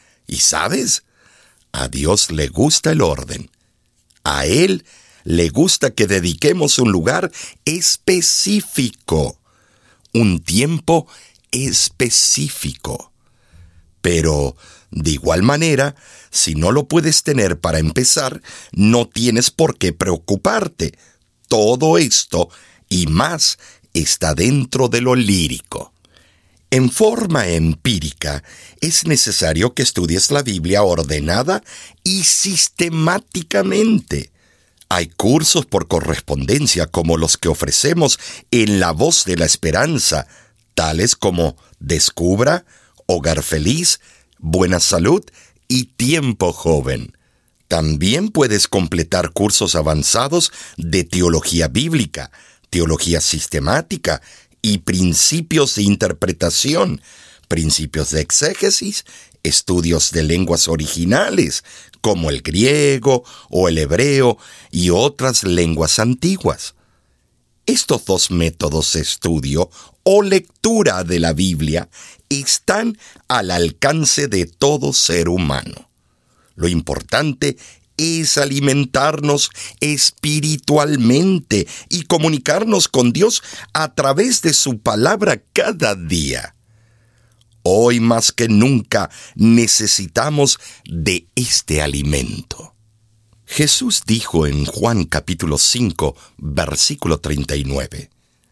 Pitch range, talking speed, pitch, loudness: 85-140 Hz, 100 wpm, 105 Hz, -16 LUFS